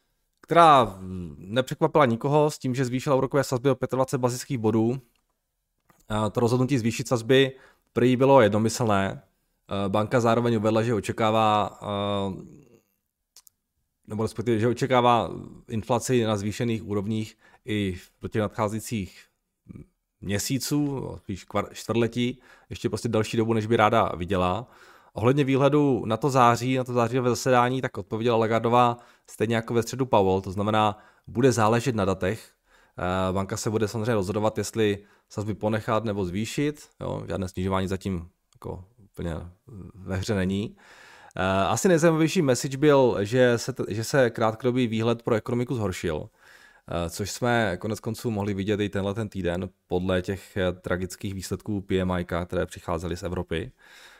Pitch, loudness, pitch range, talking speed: 110 Hz, -25 LUFS, 100-125 Hz, 135 wpm